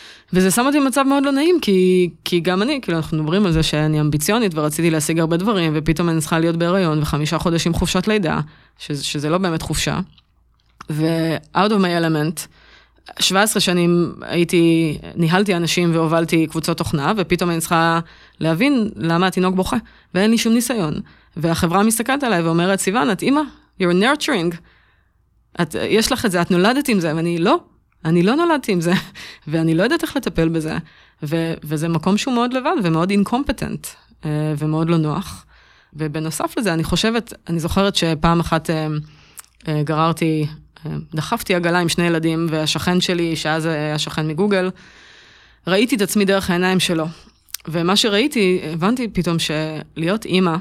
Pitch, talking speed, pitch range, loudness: 170 Hz, 160 wpm, 160-195 Hz, -18 LUFS